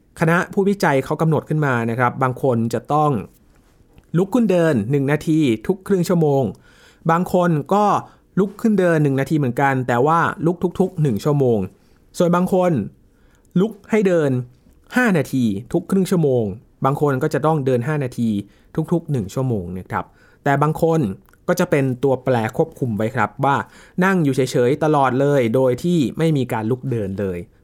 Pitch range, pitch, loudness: 125-175 Hz, 145 Hz, -19 LUFS